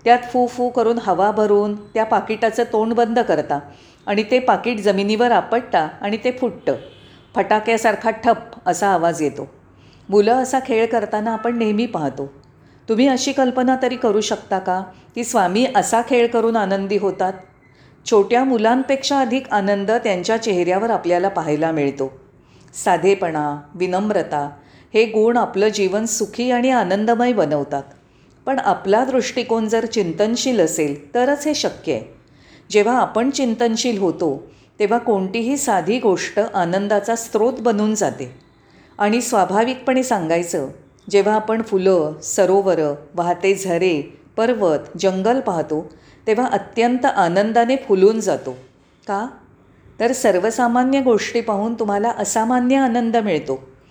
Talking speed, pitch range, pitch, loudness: 125 wpm, 185-235 Hz, 215 Hz, -18 LUFS